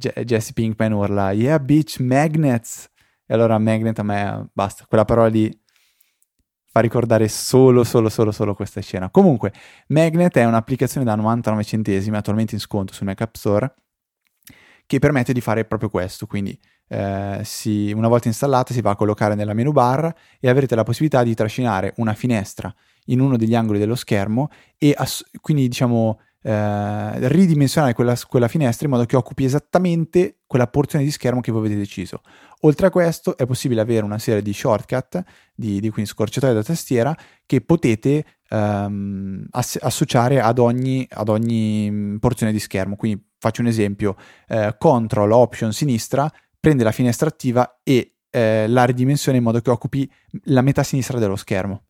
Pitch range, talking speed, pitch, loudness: 105-130 Hz, 170 wpm, 115 Hz, -19 LUFS